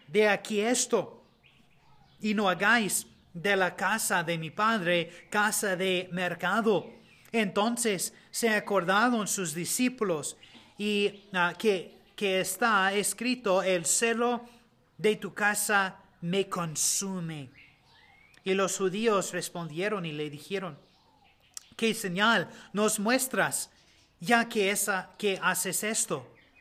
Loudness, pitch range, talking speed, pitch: -28 LUFS, 180-215 Hz, 115 wpm, 195 Hz